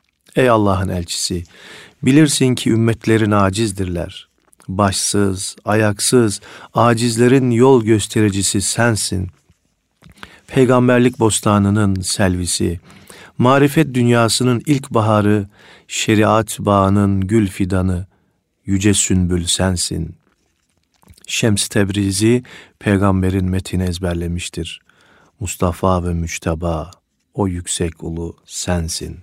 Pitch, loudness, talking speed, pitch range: 100 Hz, -16 LUFS, 80 wpm, 90-115 Hz